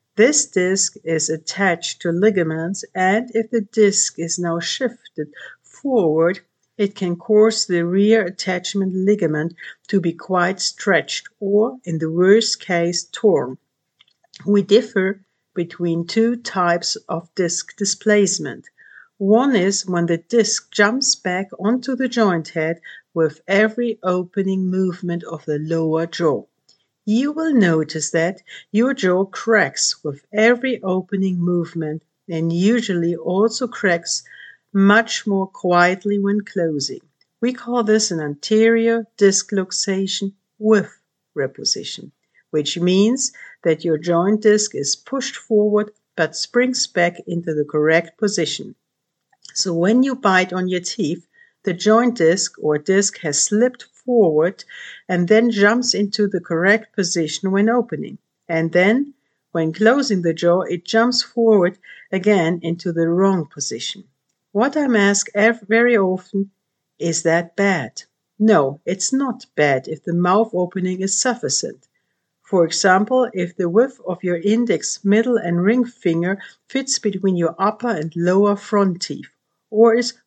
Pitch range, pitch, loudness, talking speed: 170-220 Hz, 195 Hz, -18 LUFS, 135 wpm